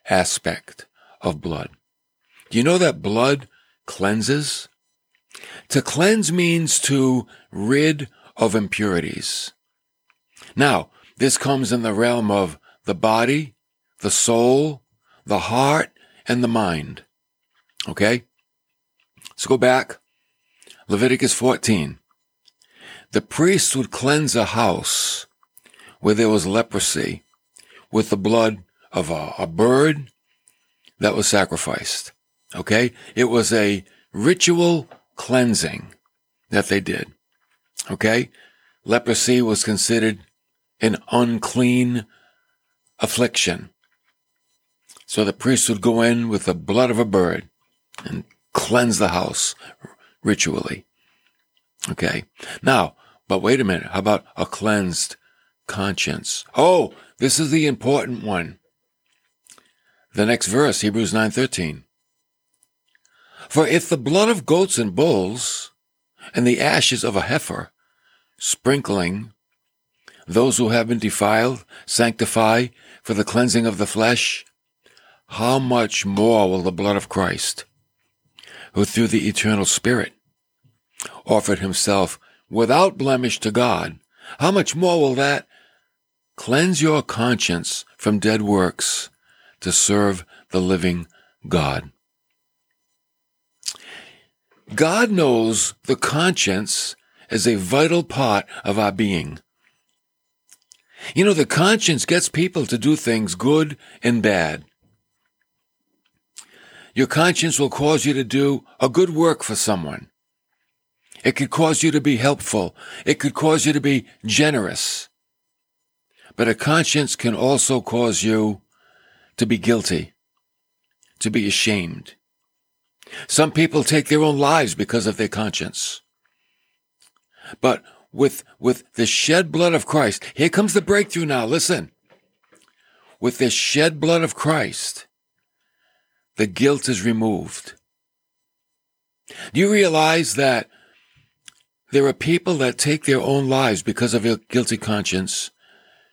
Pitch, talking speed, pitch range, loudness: 125 Hz, 120 wpm, 110-150 Hz, -19 LUFS